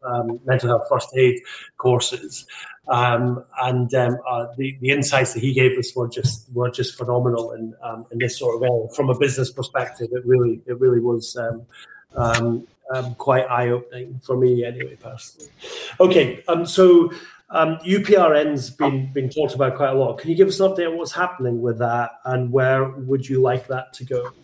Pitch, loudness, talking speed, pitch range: 125 Hz, -20 LUFS, 190 wpm, 120-135 Hz